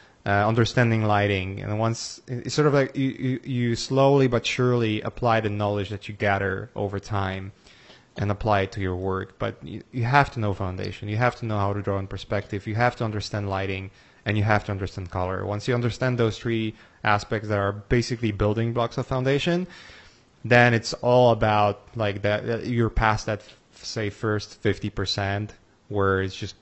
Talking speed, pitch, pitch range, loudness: 190 wpm, 105 Hz, 100-120 Hz, -24 LUFS